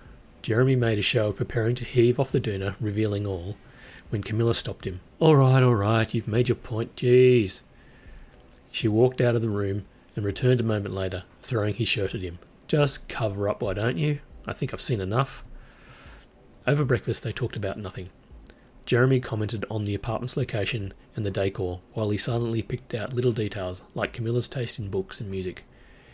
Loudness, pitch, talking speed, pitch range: -25 LUFS, 115 Hz, 190 wpm, 100-125 Hz